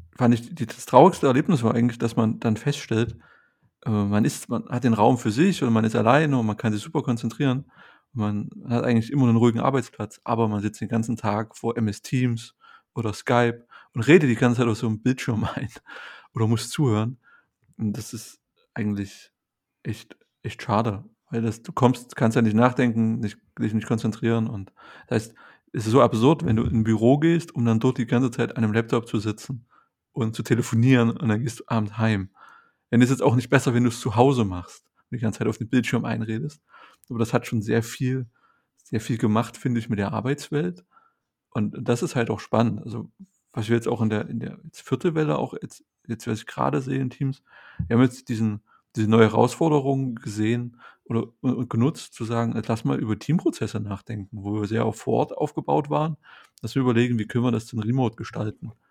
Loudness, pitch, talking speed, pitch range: -24 LUFS, 115 Hz, 210 wpm, 110-125 Hz